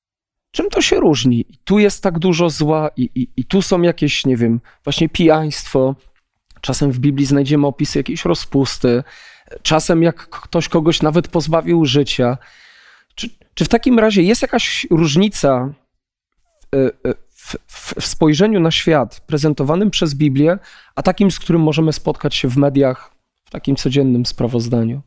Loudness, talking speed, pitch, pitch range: -15 LUFS, 150 wpm, 150 Hz, 135-175 Hz